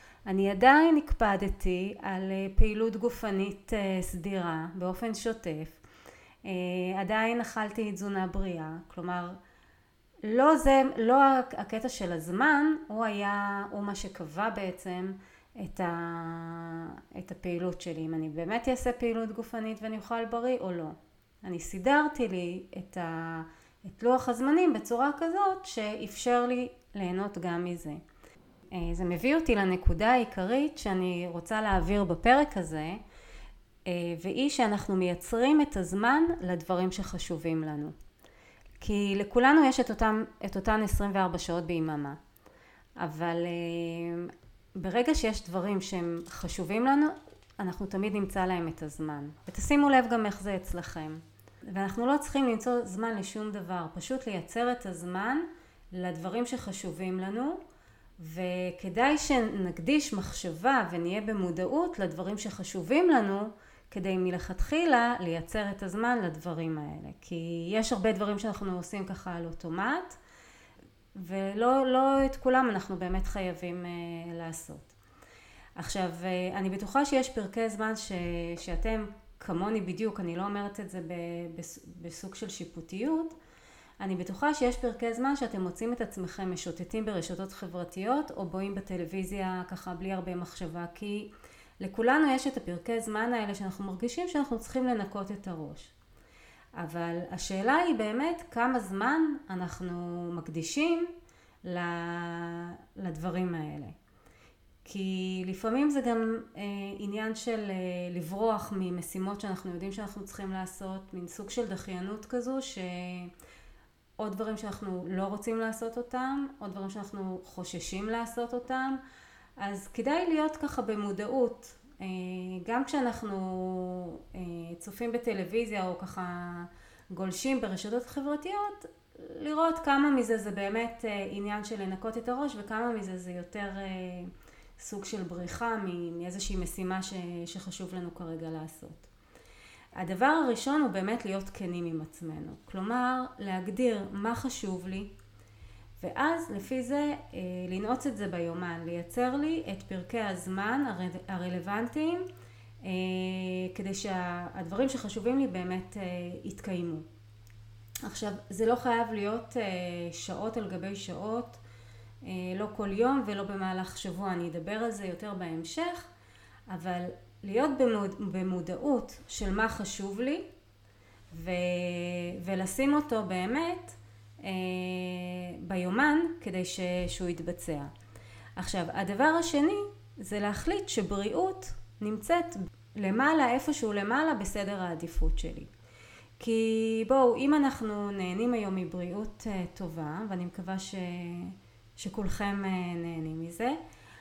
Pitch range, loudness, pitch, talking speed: 180-235 Hz, -32 LUFS, 195 Hz, 115 wpm